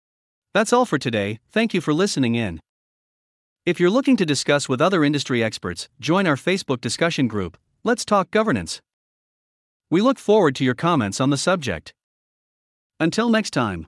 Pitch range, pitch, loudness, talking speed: 120-200 Hz, 145 Hz, -21 LUFS, 165 wpm